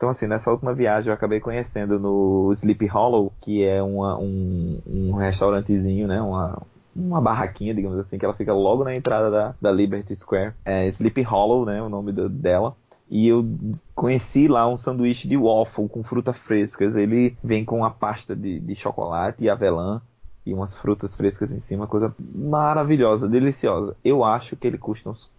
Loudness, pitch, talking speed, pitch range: -22 LUFS, 105 Hz, 180 wpm, 100-120 Hz